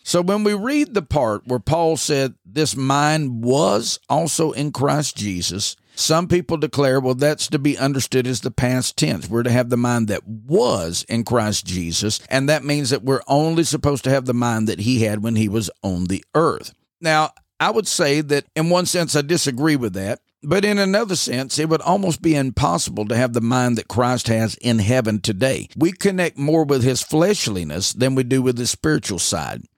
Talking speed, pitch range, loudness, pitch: 205 wpm, 115-155 Hz, -19 LUFS, 135 Hz